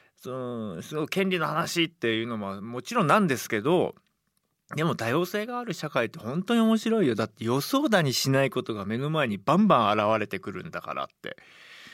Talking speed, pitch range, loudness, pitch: 380 characters per minute, 115-180 Hz, -26 LUFS, 145 Hz